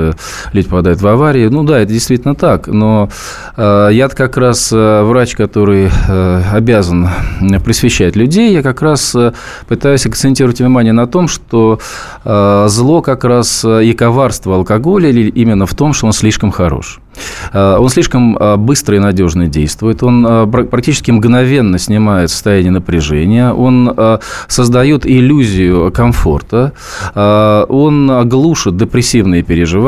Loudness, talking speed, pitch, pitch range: -9 LUFS, 120 wpm, 115 Hz, 100-125 Hz